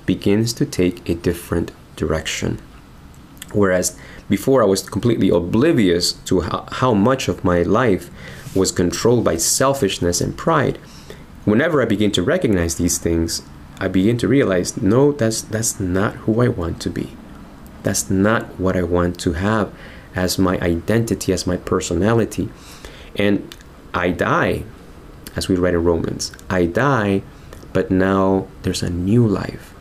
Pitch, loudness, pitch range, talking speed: 95 Hz, -19 LUFS, 85-105 Hz, 145 wpm